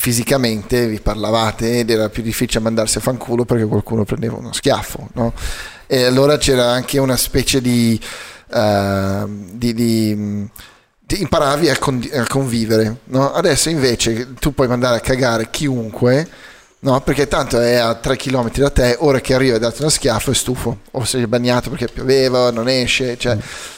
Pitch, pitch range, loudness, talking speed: 120 Hz, 115-130 Hz, -16 LUFS, 170 wpm